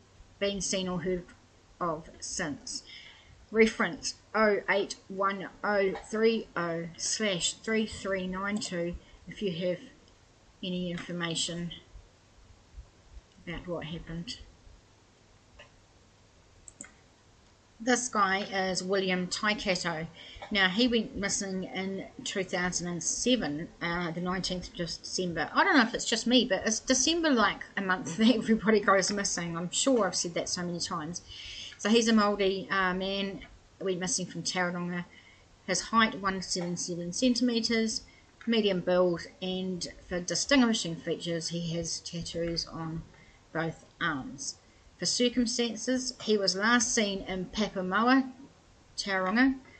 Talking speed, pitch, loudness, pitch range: 130 wpm, 185 Hz, -30 LUFS, 170-215 Hz